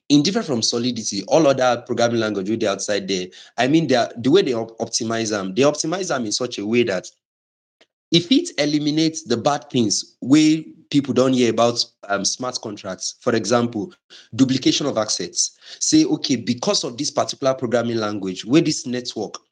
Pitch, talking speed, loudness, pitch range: 120 Hz, 180 wpm, -20 LUFS, 110-145 Hz